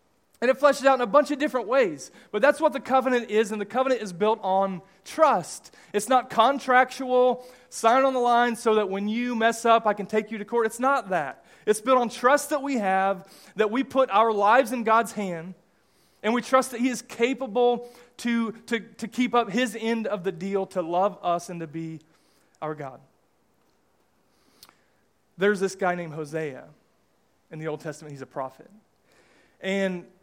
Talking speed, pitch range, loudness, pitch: 195 wpm, 190-250 Hz, -24 LUFS, 225 Hz